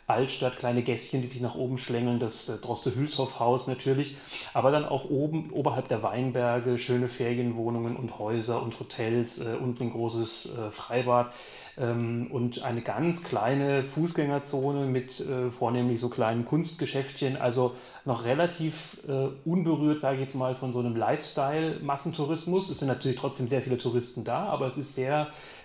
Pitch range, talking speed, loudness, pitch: 120-140 Hz, 155 wpm, -29 LUFS, 130 Hz